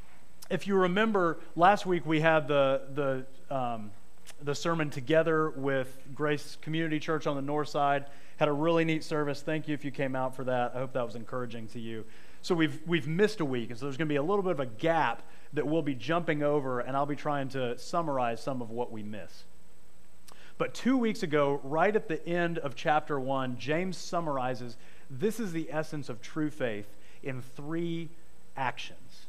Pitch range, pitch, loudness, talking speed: 130-160 Hz, 150 Hz, -31 LUFS, 200 wpm